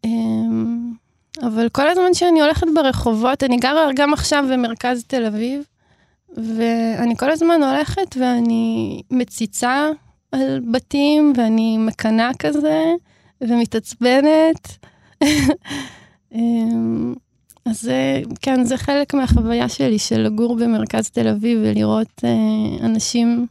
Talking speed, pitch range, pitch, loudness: 105 wpm, 225-285 Hz, 235 Hz, -18 LUFS